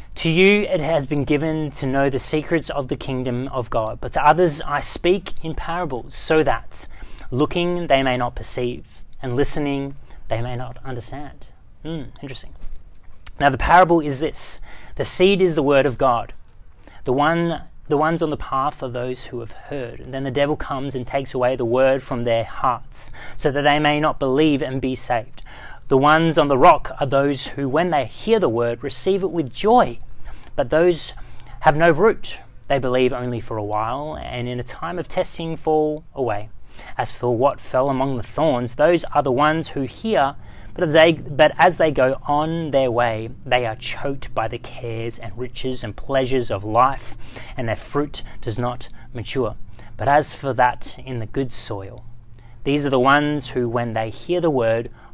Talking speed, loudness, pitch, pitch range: 195 wpm, -20 LUFS, 135 Hz, 120-150 Hz